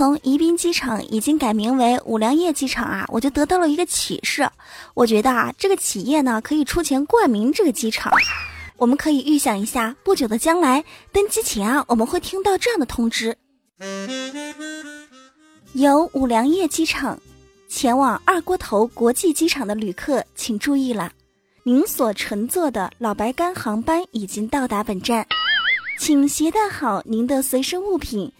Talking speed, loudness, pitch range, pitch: 250 characters per minute, -20 LUFS, 225-320 Hz, 270 Hz